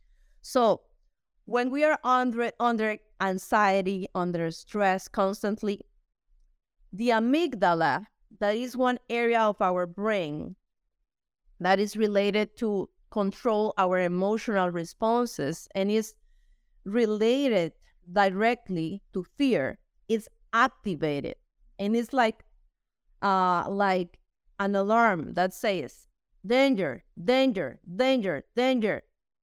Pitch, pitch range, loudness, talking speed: 210 Hz, 190-235 Hz, -27 LUFS, 100 wpm